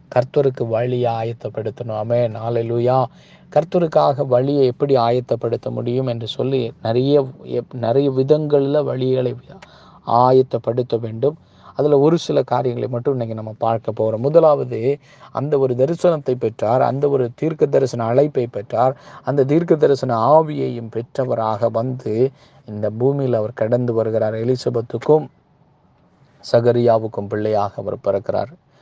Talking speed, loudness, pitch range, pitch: 110 wpm, -19 LUFS, 115-140 Hz, 125 Hz